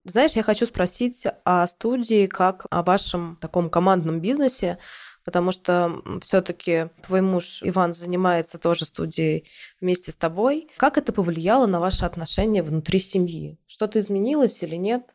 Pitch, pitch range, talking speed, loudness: 180 Hz, 175-210 Hz, 145 wpm, -23 LUFS